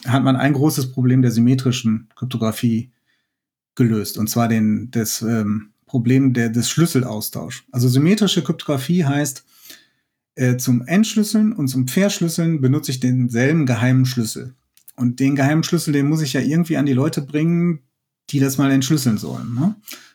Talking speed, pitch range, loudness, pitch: 150 wpm, 120-150 Hz, -18 LUFS, 135 Hz